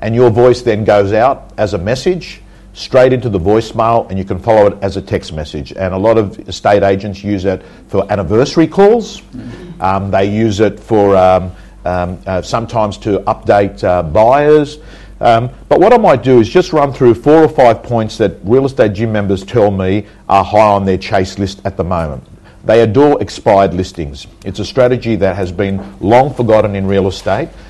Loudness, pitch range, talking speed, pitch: -12 LUFS, 95-115 Hz, 195 wpm, 105 Hz